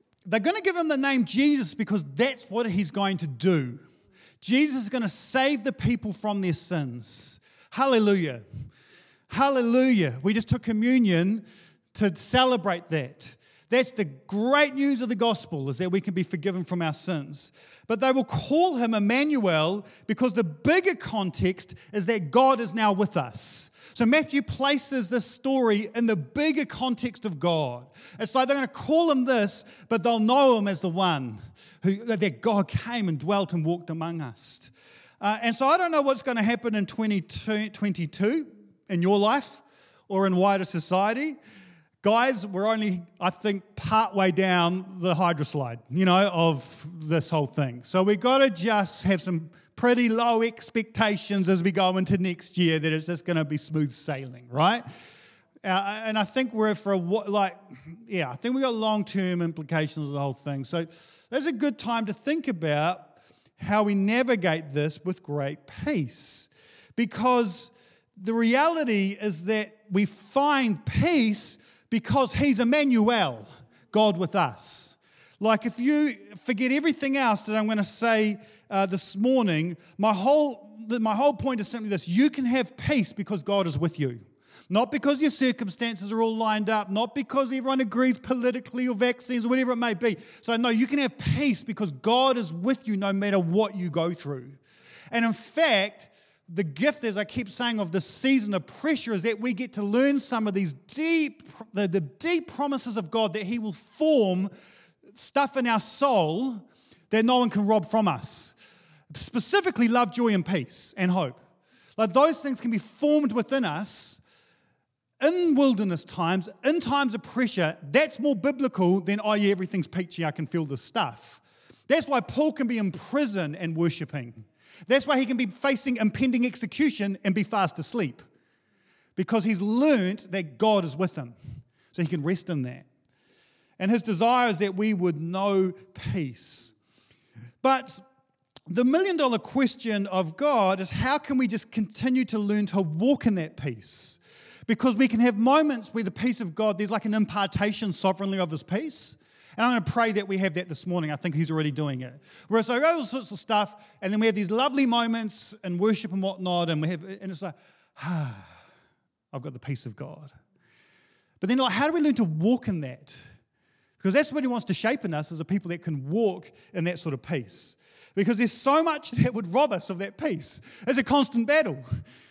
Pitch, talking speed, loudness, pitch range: 210 Hz, 185 wpm, -24 LUFS, 175-245 Hz